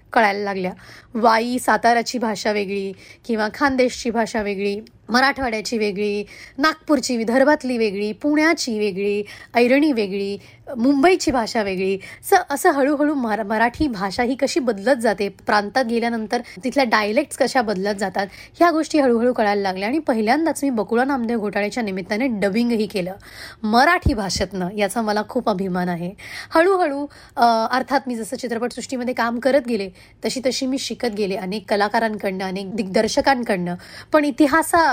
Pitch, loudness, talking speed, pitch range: 235 Hz, -20 LUFS, 135 wpm, 210-270 Hz